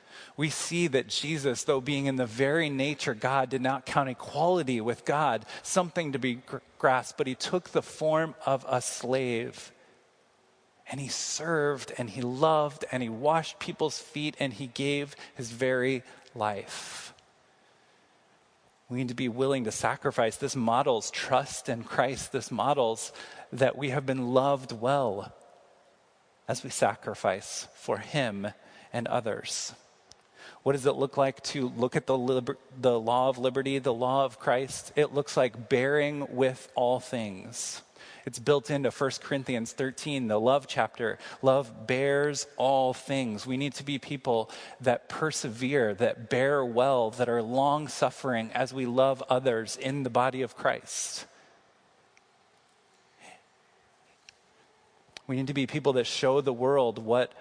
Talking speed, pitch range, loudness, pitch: 150 wpm, 125-140 Hz, -29 LUFS, 135 Hz